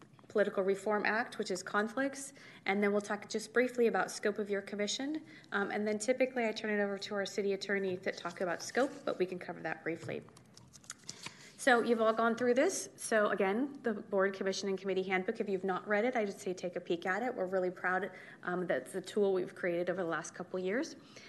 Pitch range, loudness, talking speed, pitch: 185-225 Hz, -35 LUFS, 230 wpm, 200 Hz